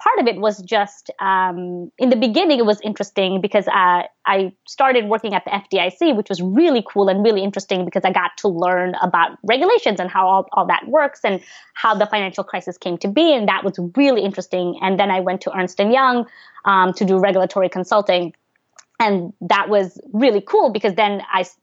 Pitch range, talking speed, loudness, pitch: 185-225 Hz, 205 wpm, -18 LUFS, 200 Hz